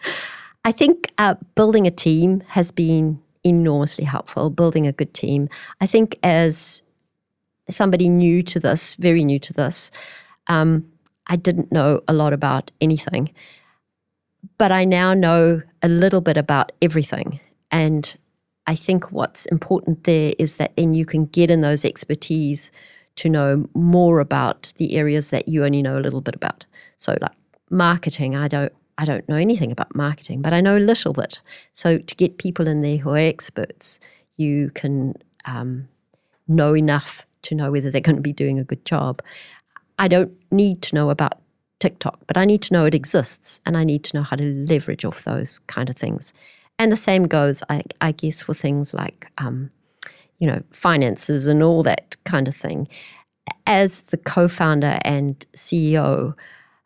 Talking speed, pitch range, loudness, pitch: 175 wpm, 145-175 Hz, -19 LUFS, 160 Hz